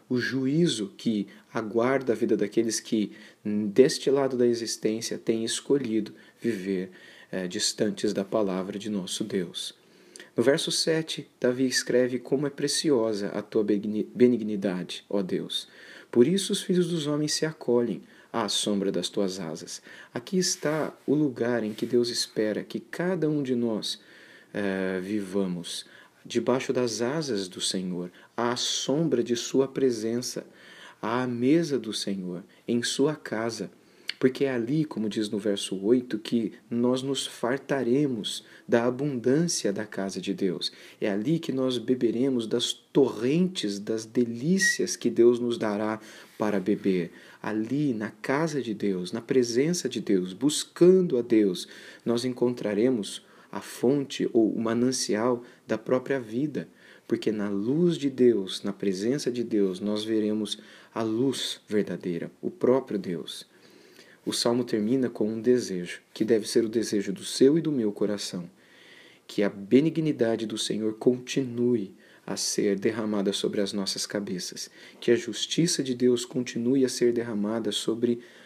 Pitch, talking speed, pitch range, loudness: 115 Hz, 145 wpm, 105-130 Hz, -27 LUFS